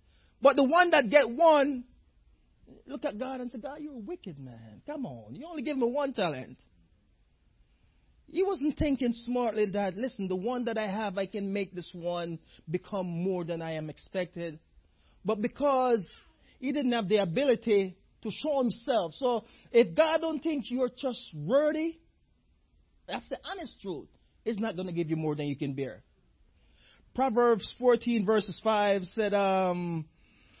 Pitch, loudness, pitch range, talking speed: 225 Hz, -29 LUFS, 180-265 Hz, 165 wpm